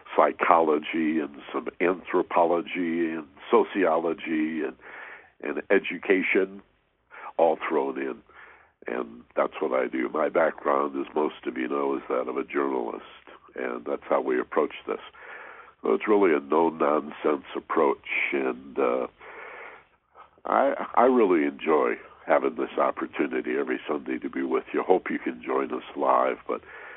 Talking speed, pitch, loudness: 140 wpm, 400 Hz, -26 LUFS